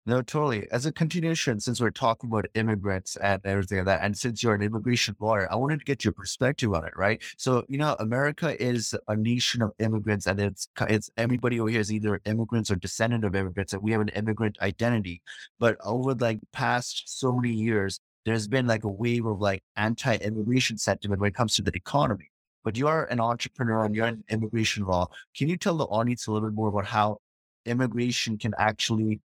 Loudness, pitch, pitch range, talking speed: -27 LUFS, 110 Hz, 105-120 Hz, 215 wpm